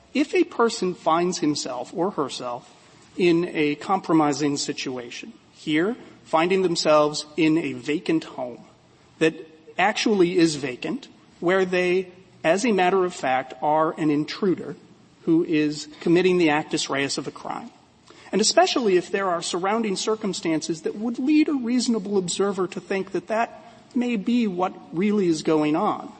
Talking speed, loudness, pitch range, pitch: 150 wpm, -23 LUFS, 155-205 Hz, 175 Hz